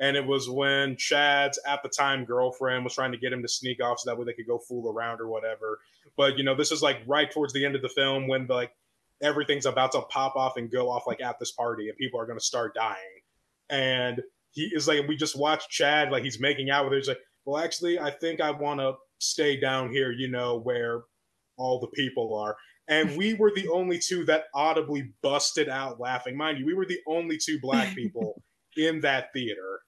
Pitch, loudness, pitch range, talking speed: 135 Hz, -27 LUFS, 125-150 Hz, 230 wpm